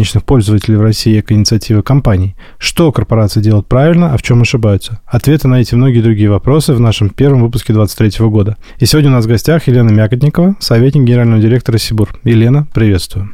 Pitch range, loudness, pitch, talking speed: 110-130 Hz, -10 LUFS, 115 Hz, 180 wpm